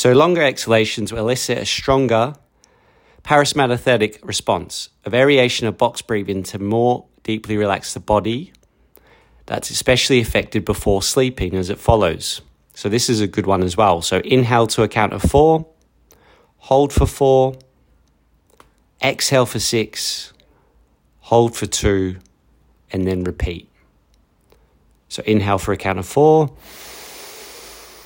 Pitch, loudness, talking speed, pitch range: 110 Hz, -18 LUFS, 135 wpm, 95-130 Hz